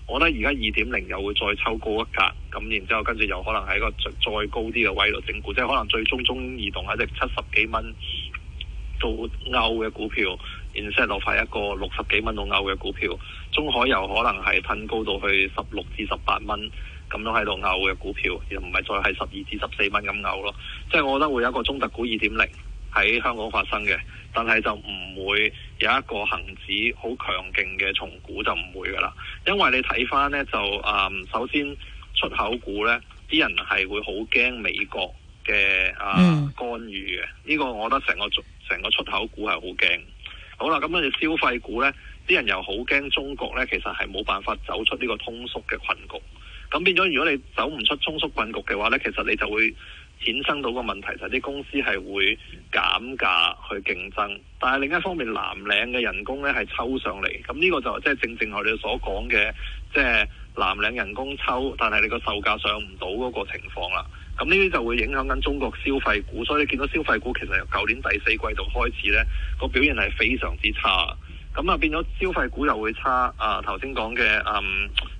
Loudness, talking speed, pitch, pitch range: -23 LUFS, 295 characters per minute, 110 Hz, 95-130 Hz